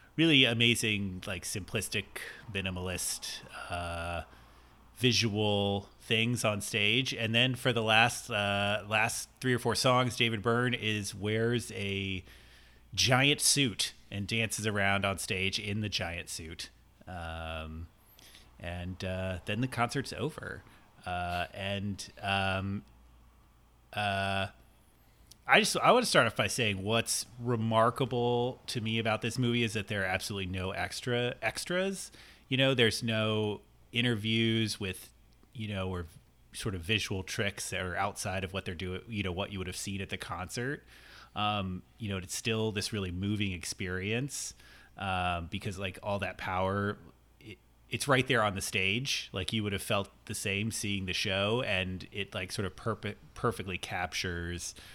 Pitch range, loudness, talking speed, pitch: 95-115 Hz, -31 LUFS, 155 wpm, 100 Hz